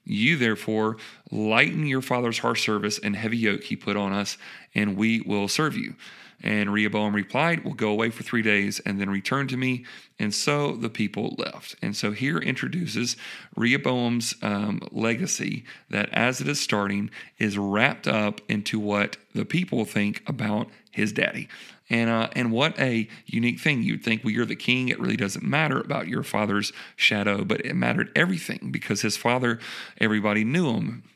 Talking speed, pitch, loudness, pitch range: 175 wpm, 110 Hz, -25 LUFS, 105-120 Hz